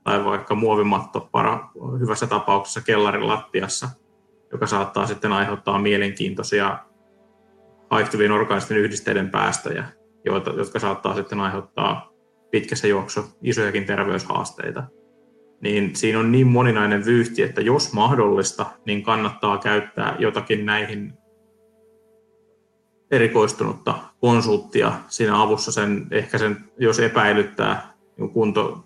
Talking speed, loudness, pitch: 100 wpm, -21 LUFS, 110 Hz